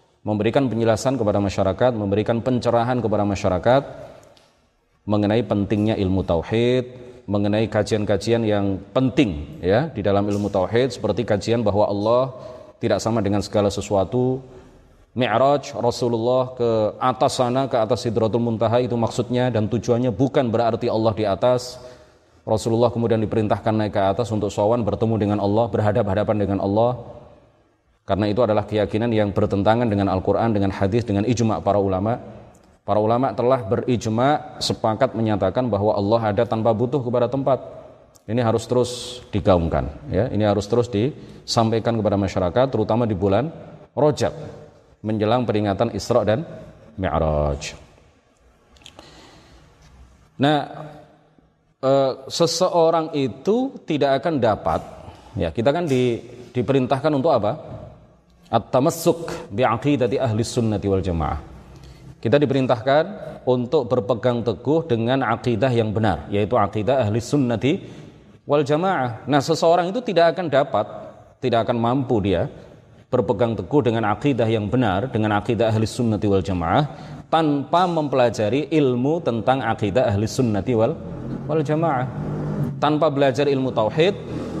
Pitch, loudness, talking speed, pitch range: 120 Hz, -21 LUFS, 125 wpm, 105-130 Hz